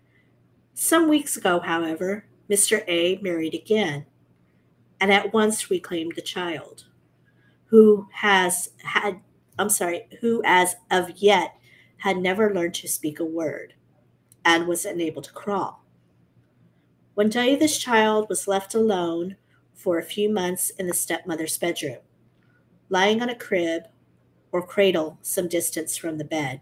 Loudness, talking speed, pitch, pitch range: -23 LUFS, 140 wpm, 180 Hz, 165-205 Hz